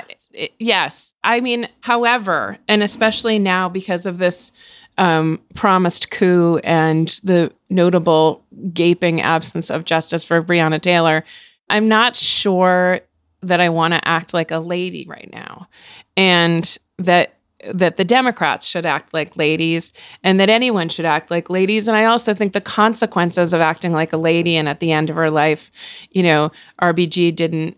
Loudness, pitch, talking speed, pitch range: -16 LUFS, 175 Hz, 165 wpm, 165-200 Hz